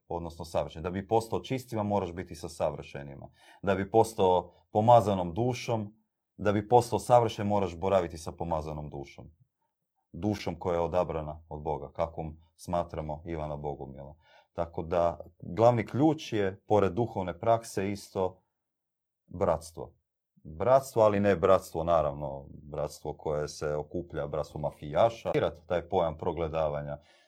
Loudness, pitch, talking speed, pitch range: -30 LUFS, 90 Hz, 130 wpm, 80-105 Hz